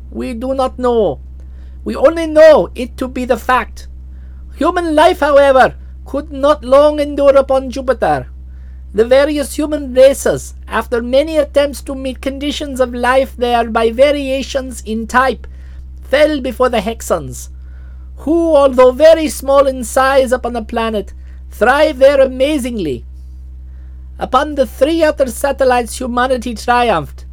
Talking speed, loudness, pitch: 135 wpm, -13 LUFS, 255 Hz